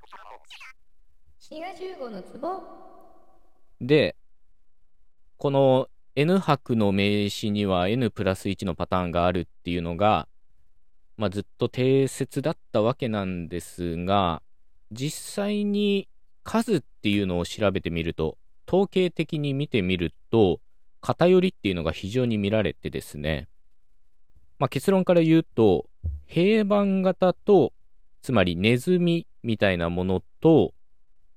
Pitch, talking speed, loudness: 105 Hz, 210 characters per minute, -24 LUFS